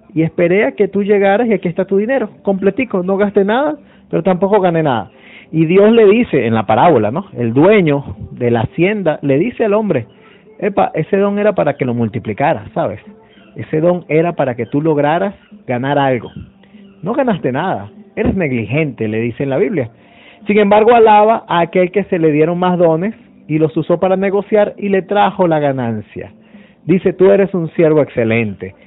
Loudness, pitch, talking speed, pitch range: -14 LUFS, 180 Hz, 190 wpm, 145-205 Hz